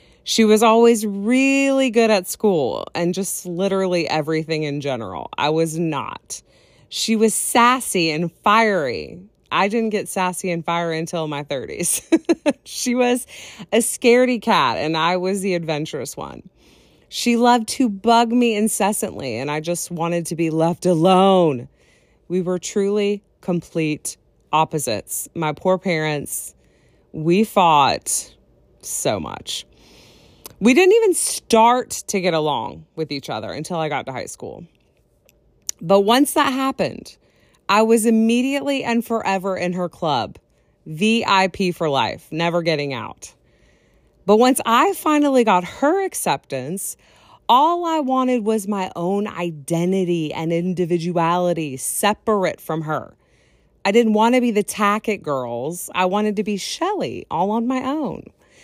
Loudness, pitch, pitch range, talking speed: -19 LUFS, 195 Hz, 165-230 Hz, 140 wpm